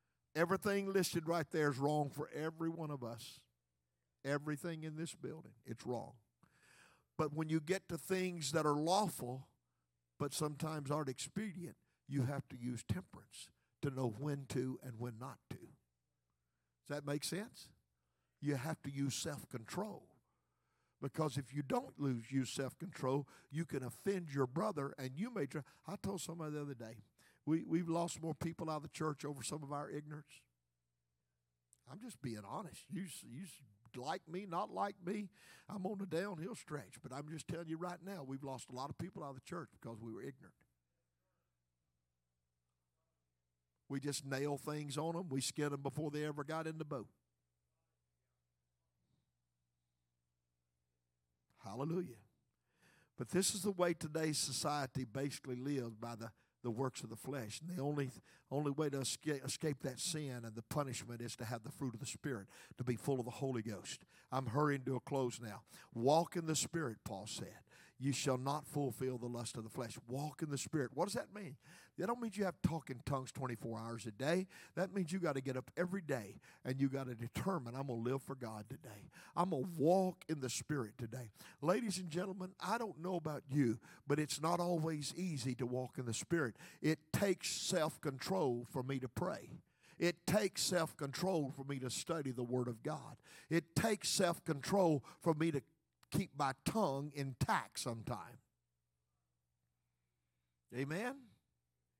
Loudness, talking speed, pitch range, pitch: -41 LUFS, 180 wpm, 115-160 Hz, 140 Hz